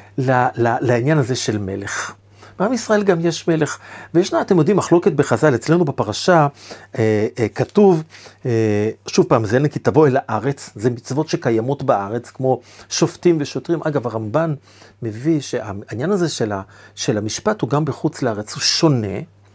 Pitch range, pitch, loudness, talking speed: 110-155 Hz, 130 Hz, -18 LUFS, 155 wpm